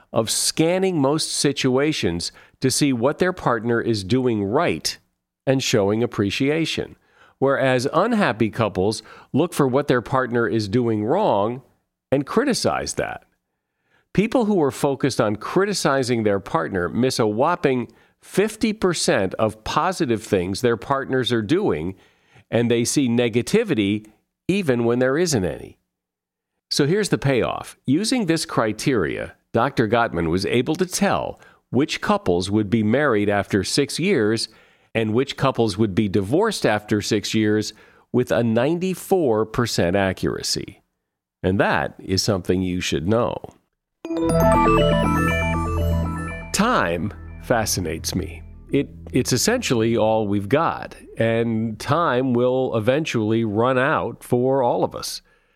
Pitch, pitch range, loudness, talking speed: 120 Hz, 105-140 Hz, -21 LUFS, 125 wpm